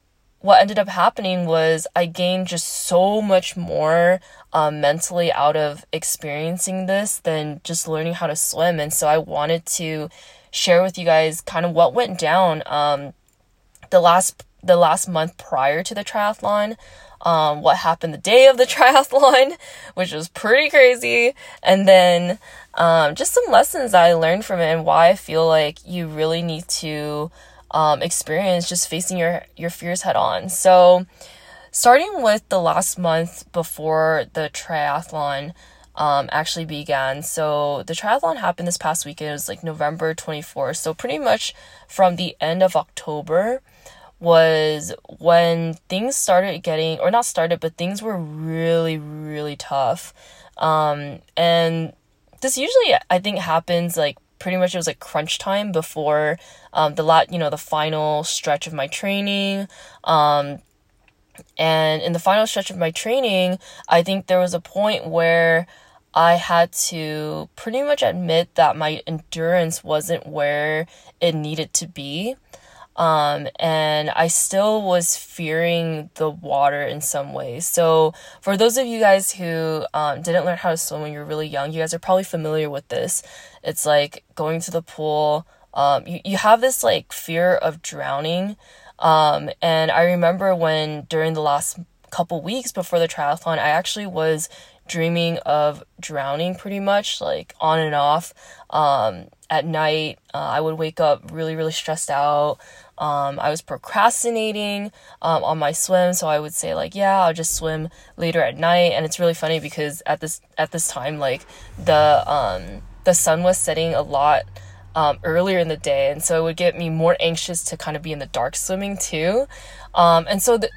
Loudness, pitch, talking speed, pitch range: -19 LUFS, 165 Hz, 170 wpm, 155-180 Hz